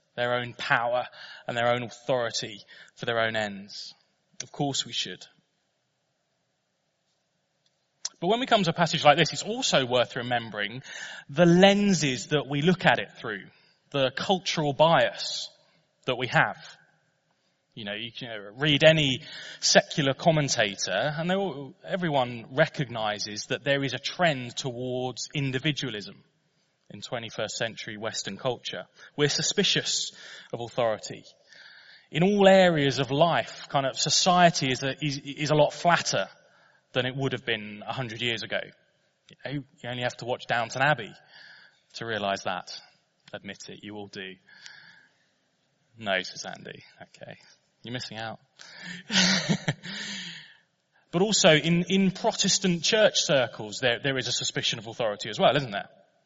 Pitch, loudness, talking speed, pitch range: 140 Hz, -26 LUFS, 145 wpm, 120-170 Hz